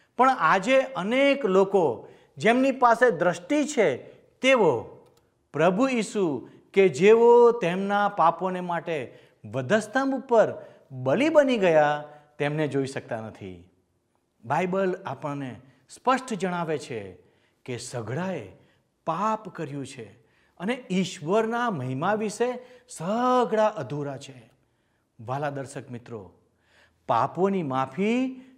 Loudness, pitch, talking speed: -24 LUFS, 180 Hz, 95 wpm